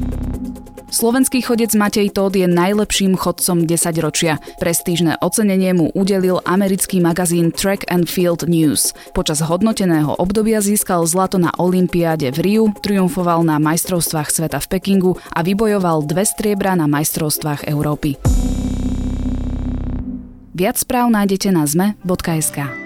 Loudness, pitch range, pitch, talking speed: -16 LUFS, 155-195 Hz, 175 Hz, 120 wpm